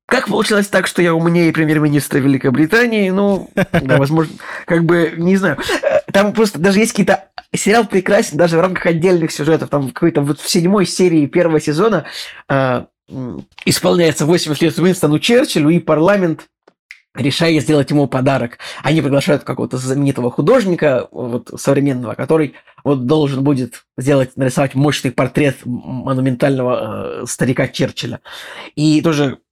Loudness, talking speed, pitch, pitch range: -15 LUFS, 135 wpm, 155 Hz, 140-180 Hz